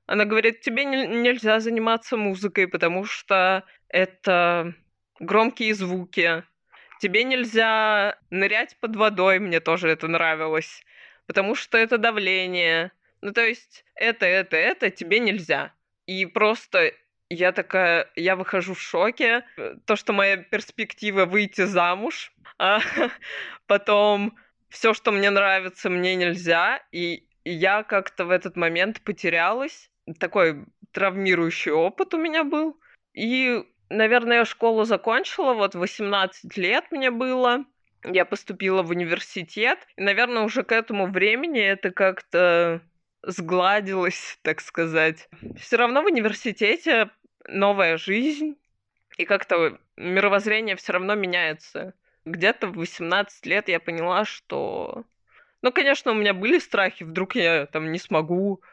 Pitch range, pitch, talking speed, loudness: 180-225 Hz, 200 Hz, 125 wpm, -22 LUFS